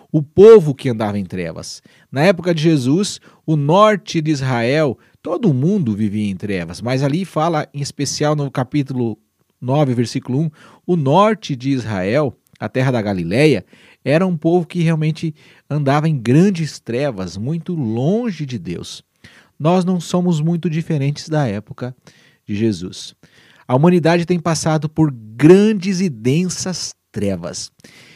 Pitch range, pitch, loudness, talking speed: 125-170 Hz, 150 Hz, -17 LUFS, 145 wpm